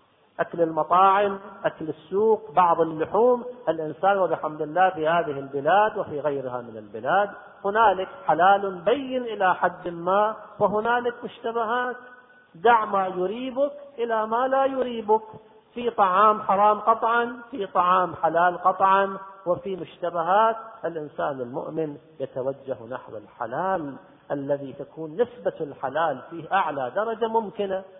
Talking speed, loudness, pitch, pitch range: 115 wpm, -24 LUFS, 195 Hz, 165-225 Hz